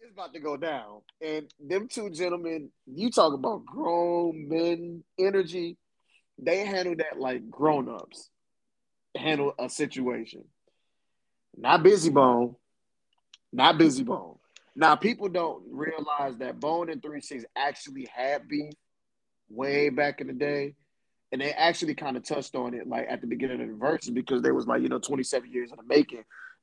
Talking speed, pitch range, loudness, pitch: 160 wpm, 145-180 Hz, -27 LUFS, 155 Hz